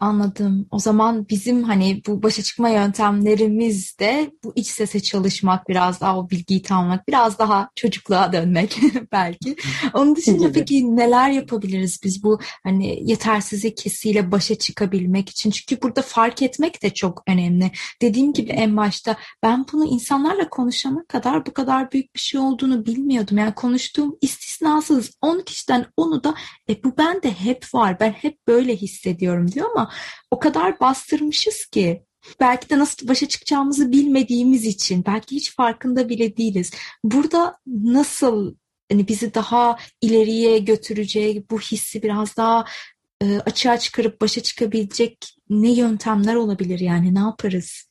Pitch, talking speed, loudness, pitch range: 225 Hz, 145 wpm, -19 LUFS, 205-265 Hz